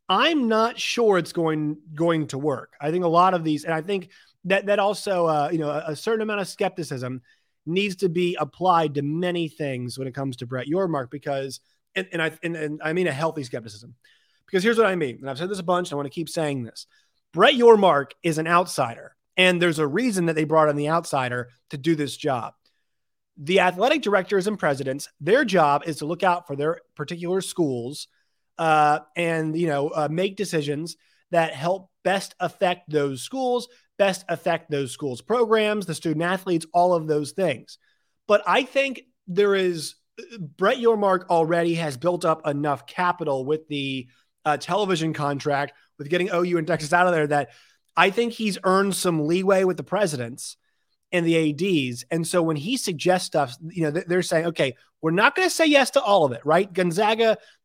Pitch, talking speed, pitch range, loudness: 170 Hz, 200 wpm, 150-190 Hz, -23 LUFS